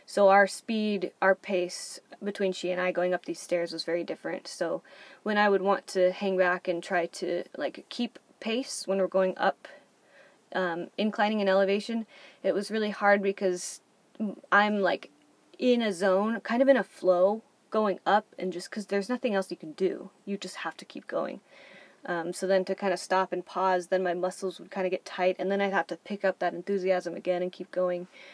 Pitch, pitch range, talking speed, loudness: 190 Hz, 180-205 Hz, 210 wpm, -29 LUFS